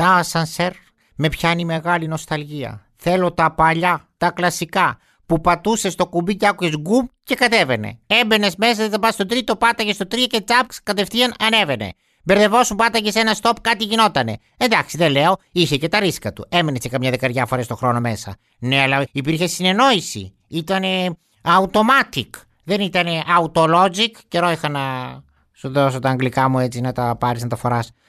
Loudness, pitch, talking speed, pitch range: -18 LUFS, 175 Hz, 175 wpm, 130-210 Hz